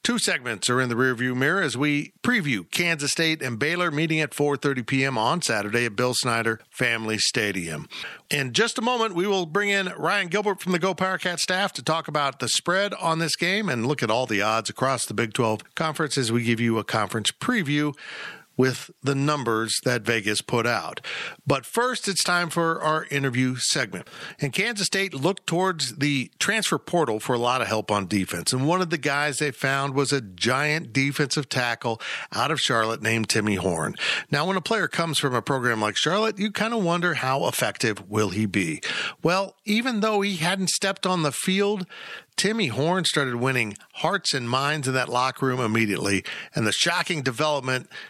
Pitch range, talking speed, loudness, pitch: 120-180 Hz, 200 wpm, -24 LUFS, 145 Hz